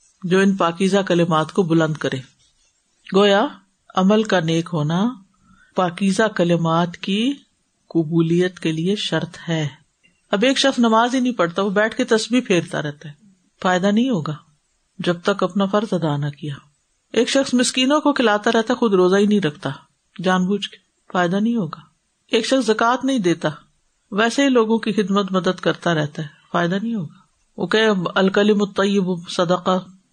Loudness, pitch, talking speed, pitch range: -19 LUFS, 190 Hz, 165 wpm, 170-220 Hz